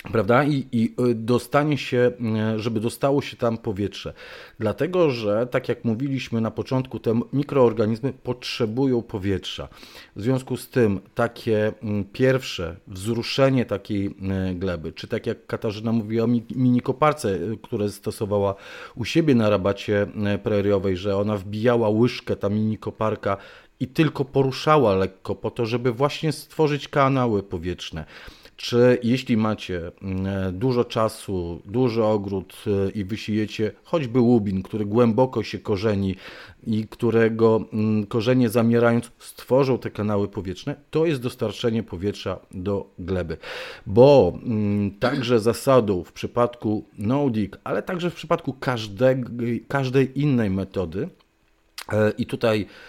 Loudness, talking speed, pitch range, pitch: -23 LUFS, 120 wpm, 100-125 Hz, 115 Hz